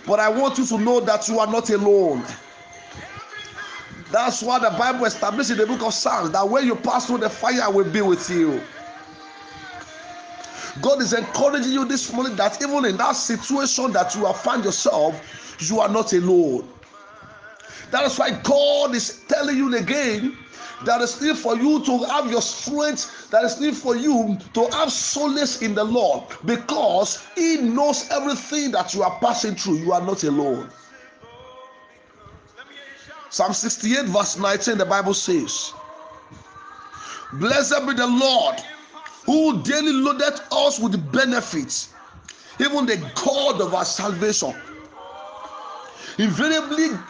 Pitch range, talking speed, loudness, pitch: 215-295 Hz, 150 wpm, -21 LUFS, 250 Hz